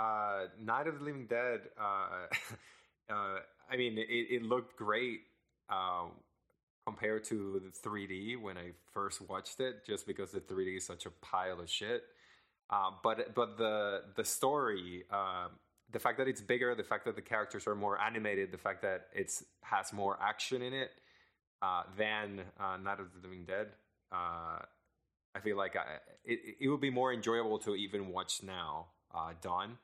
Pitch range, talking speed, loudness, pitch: 95-125 Hz, 175 wpm, -38 LUFS, 105 Hz